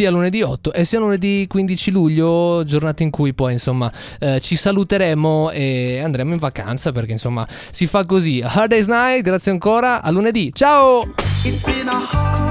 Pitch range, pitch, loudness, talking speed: 130-200 Hz, 165 Hz, -17 LUFS, 160 wpm